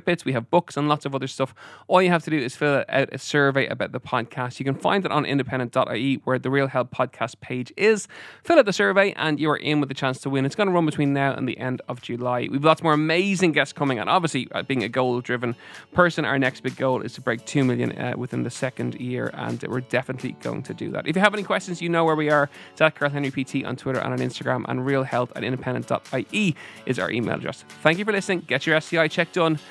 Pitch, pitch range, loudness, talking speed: 140 Hz, 130-160 Hz, -23 LUFS, 255 wpm